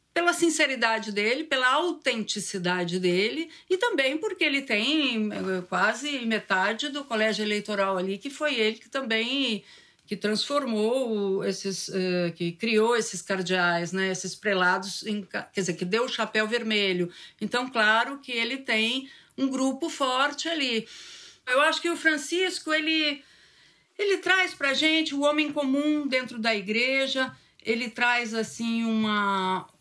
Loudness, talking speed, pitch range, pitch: -26 LUFS, 140 wpm, 205-285 Hz, 230 Hz